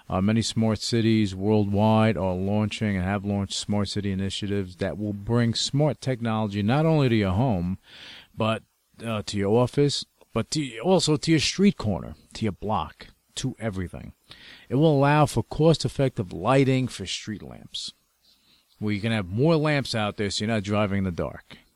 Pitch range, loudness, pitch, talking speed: 100-130 Hz, -25 LUFS, 110 Hz, 180 wpm